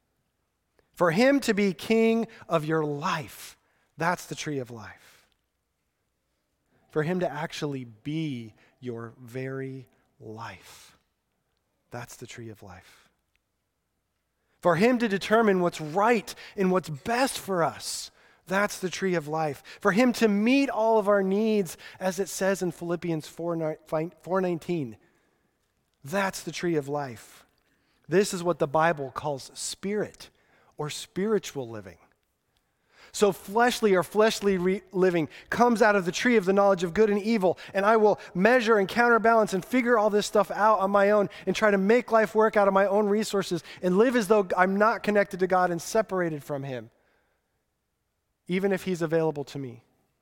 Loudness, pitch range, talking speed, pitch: -25 LUFS, 155-210 Hz, 160 wpm, 185 Hz